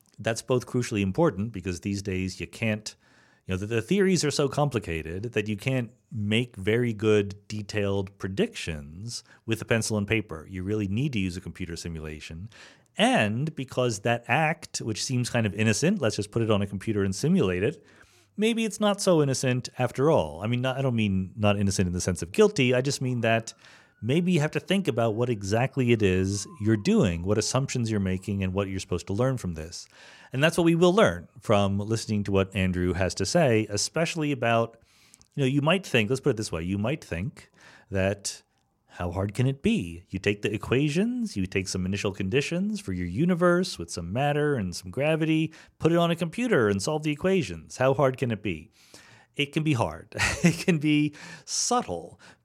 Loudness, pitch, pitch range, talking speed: -26 LUFS, 115 Hz, 100-145 Hz, 205 wpm